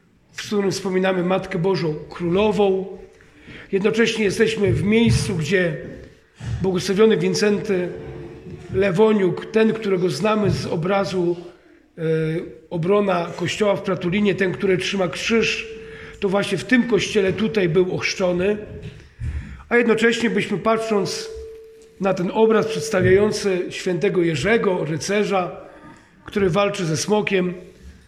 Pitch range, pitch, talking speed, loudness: 185-215 Hz, 195 Hz, 105 wpm, -20 LUFS